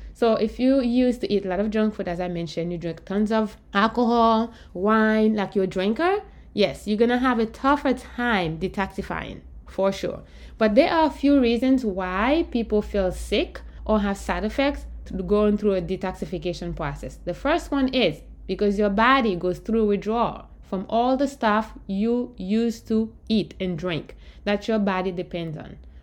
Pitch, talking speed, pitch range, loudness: 210 Hz, 180 wpm, 190-235 Hz, -23 LUFS